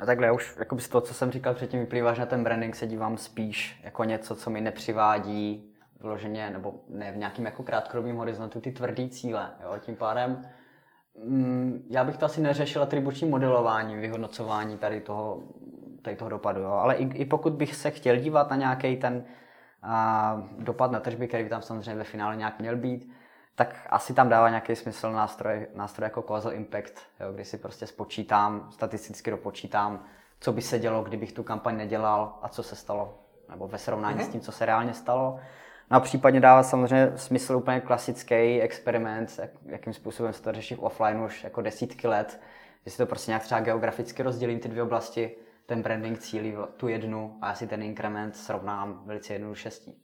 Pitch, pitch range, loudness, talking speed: 115 Hz, 110-125 Hz, -28 LUFS, 190 wpm